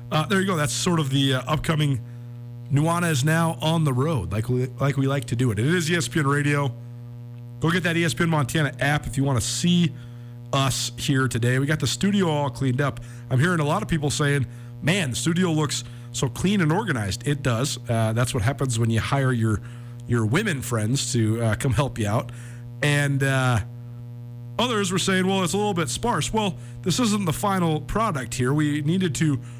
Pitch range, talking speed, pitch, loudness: 120-155 Hz, 210 wpm, 135 Hz, -23 LUFS